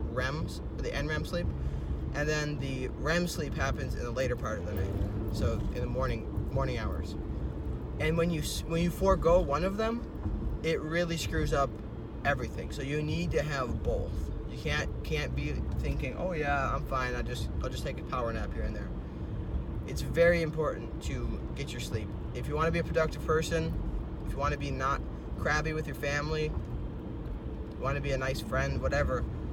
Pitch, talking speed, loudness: 145 Hz, 195 wpm, -33 LUFS